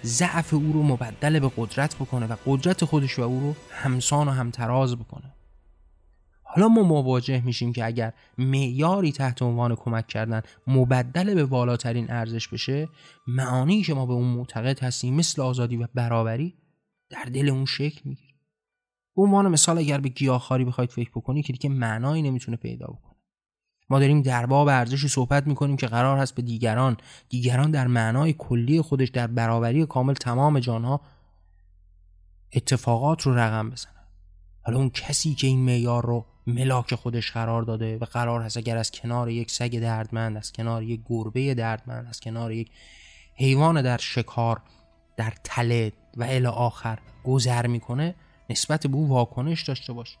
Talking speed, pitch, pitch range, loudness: 160 wpm, 125 Hz, 115-140 Hz, -24 LUFS